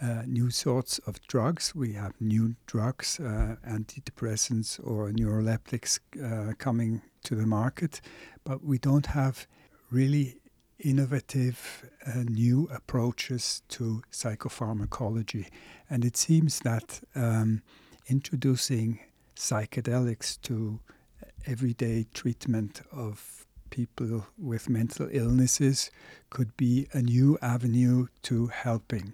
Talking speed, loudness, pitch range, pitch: 105 wpm, -29 LUFS, 115-130 Hz, 120 Hz